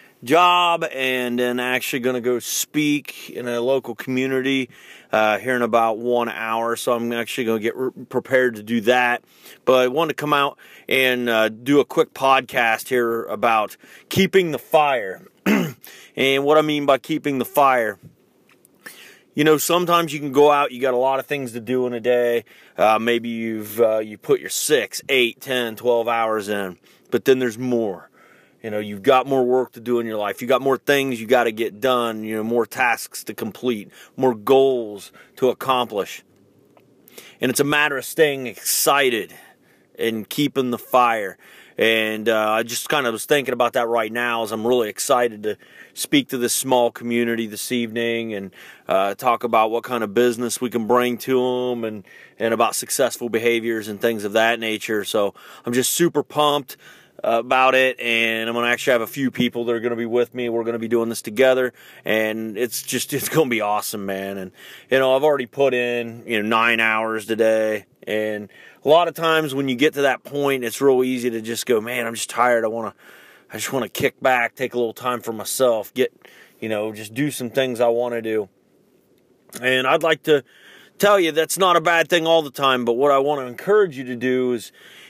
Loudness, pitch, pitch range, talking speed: -20 LUFS, 120 Hz, 115-135 Hz, 210 wpm